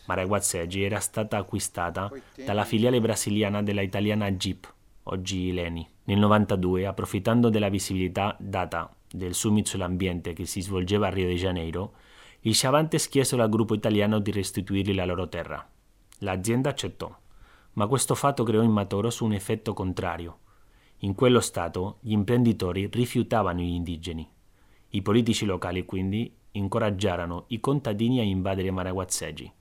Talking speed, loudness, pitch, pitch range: 140 wpm, -26 LUFS, 100 Hz, 95-110 Hz